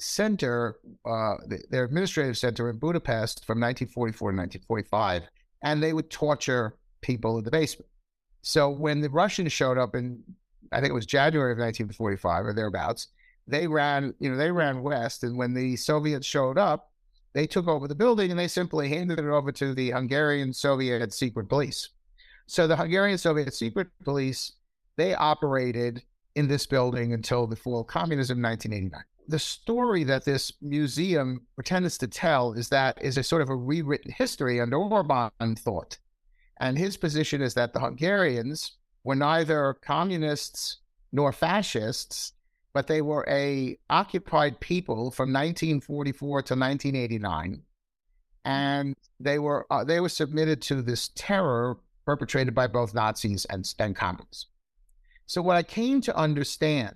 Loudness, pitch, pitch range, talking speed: -27 LUFS, 140 Hz, 120-155 Hz, 155 wpm